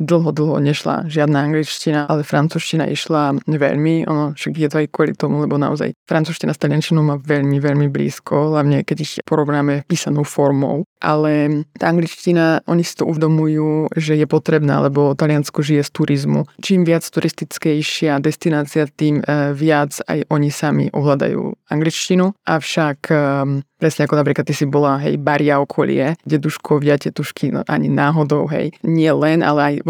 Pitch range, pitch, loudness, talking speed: 145-160 Hz, 150 Hz, -17 LUFS, 155 wpm